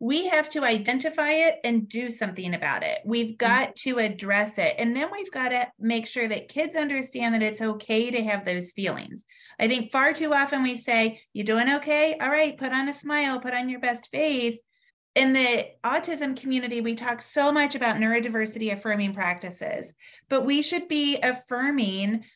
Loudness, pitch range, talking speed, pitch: -25 LUFS, 225-290 Hz, 190 wpm, 245 Hz